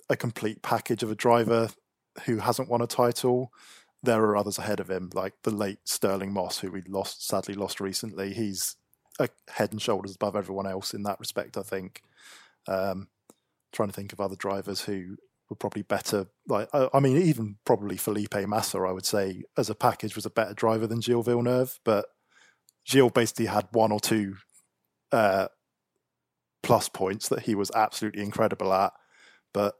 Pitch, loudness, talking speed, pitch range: 105 Hz, -28 LUFS, 180 wpm, 100-115 Hz